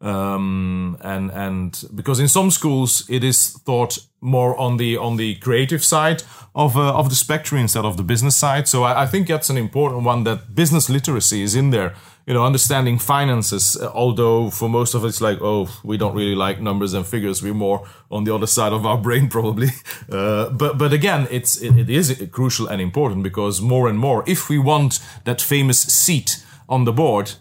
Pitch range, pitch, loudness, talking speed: 105-135 Hz, 120 Hz, -18 LUFS, 205 wpm